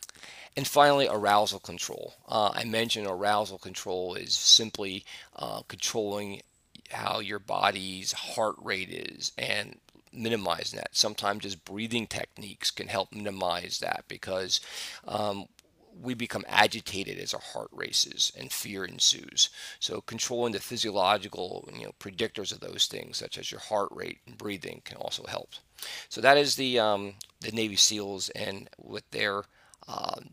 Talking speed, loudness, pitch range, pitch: 145 wpm, -28 LUFS, 100-115 Hz, 105 Hz